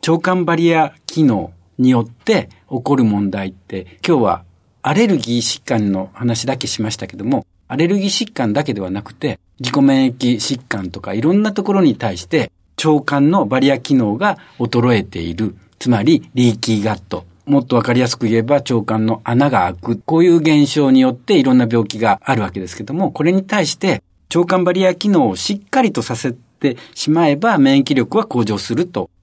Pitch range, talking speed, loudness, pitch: 110-160 Hz, 360 characters per minute, -16 LUFS, 125 Hz